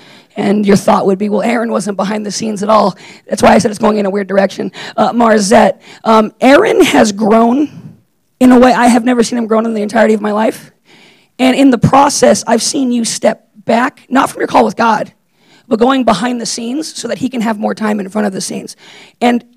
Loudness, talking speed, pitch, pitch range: -11 LUFS, 235 wpm, 225 Hz, 210-240 Hz